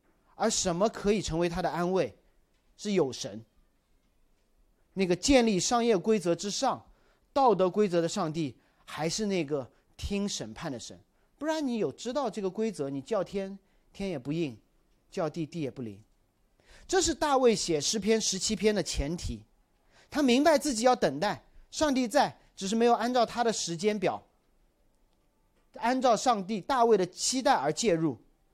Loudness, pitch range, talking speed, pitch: -29 LUFS, 165-235 Hz, 230 characters per minute, 200 Hz